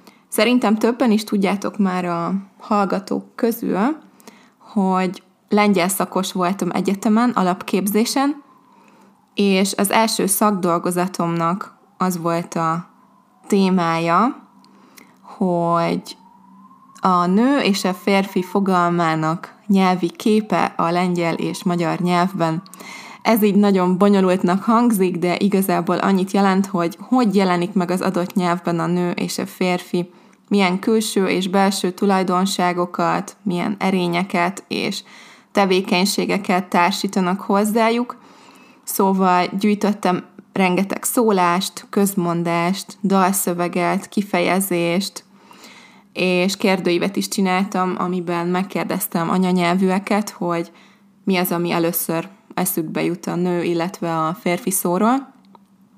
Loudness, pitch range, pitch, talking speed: -19 LUFS, 175-210 Hz, 190 Hz, 100 wpm